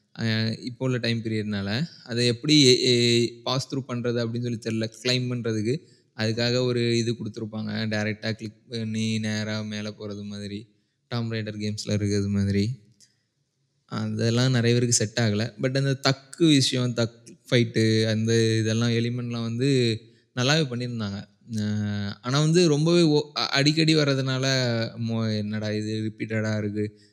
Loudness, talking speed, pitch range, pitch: -24 LUFS, 130 wpm, 110-125 Hz, 115 Hz